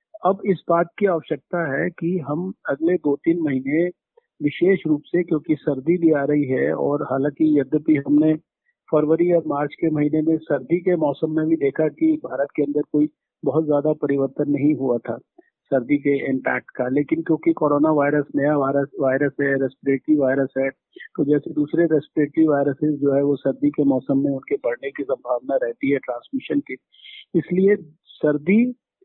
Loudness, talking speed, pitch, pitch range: -21 LUFS, 175 wpm, 150 Hz, 140-170 Hz